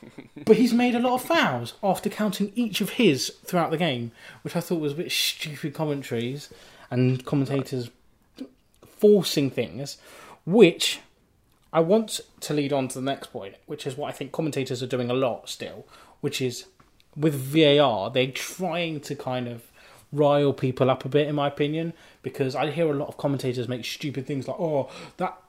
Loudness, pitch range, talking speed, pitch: -25 LUFS, 130-165 Hz, 185 wpm, 145 Hz